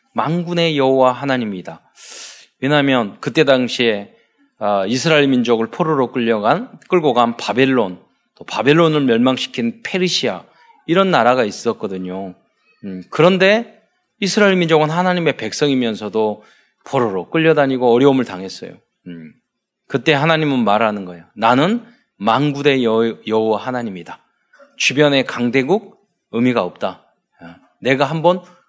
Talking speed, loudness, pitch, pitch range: 300 characters per minute, -16 LUFS, 135 Hz, 115-170 Hz